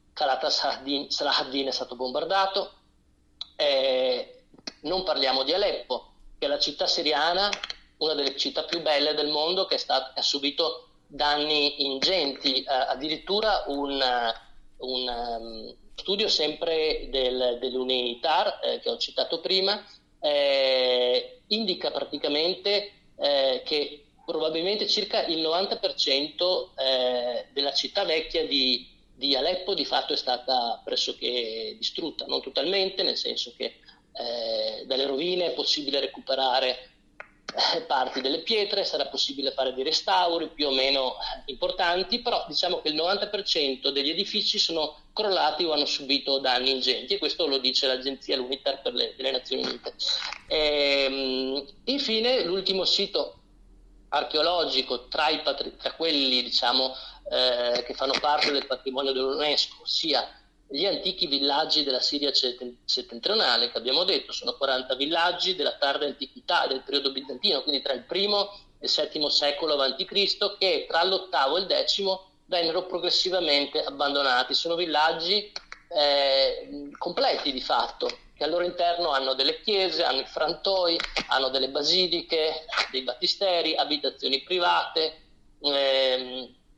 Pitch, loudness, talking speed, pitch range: 150 Hz, -25 LUFS, 135 wpm, 135-185 Hz